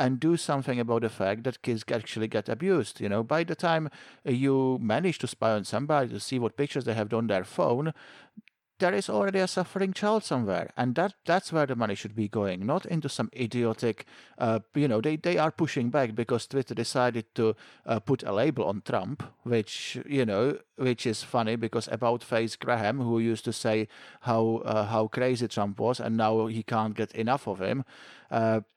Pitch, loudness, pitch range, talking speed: 120 Hz, -29 LUFS, 110-140 Hz, 205 wpm